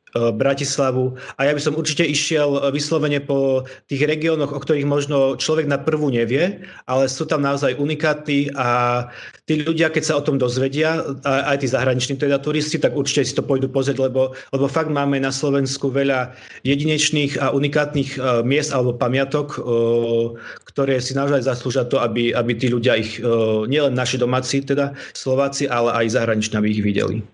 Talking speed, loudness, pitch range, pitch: 165 wpm, -19 LUFS, 125-145 Hz, 140 Hz